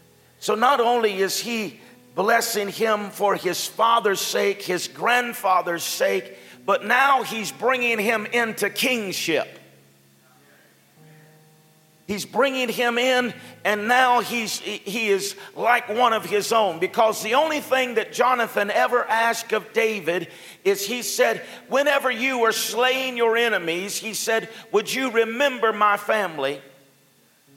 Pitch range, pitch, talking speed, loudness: 180-235 Hz, 215 Hz, 135 wpm, -22 LUFS